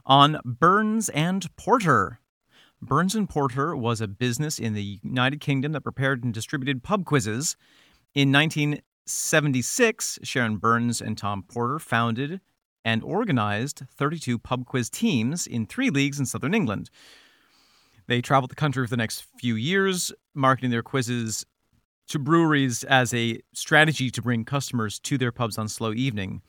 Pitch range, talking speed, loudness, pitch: 115-150 Hz, 150 wpm, -24 LUFS, 130 Hz